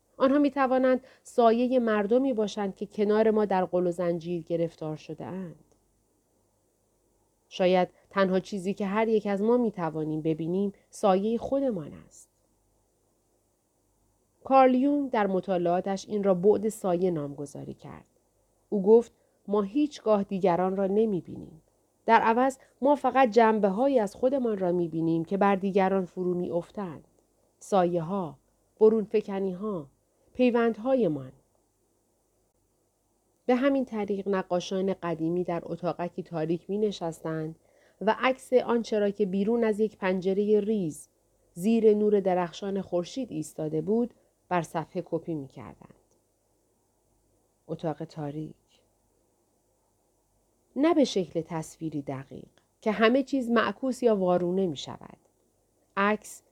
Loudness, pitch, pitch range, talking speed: -27 LUFS, 195 Hz, 170-220 Hz, 125 wpm